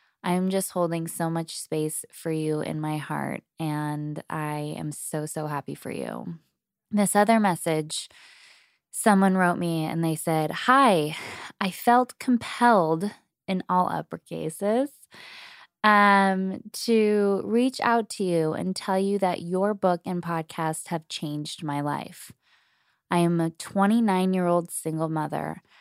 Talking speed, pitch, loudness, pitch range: 135 wpm, 180 Hz, -25 LUFS, 160-205 Hz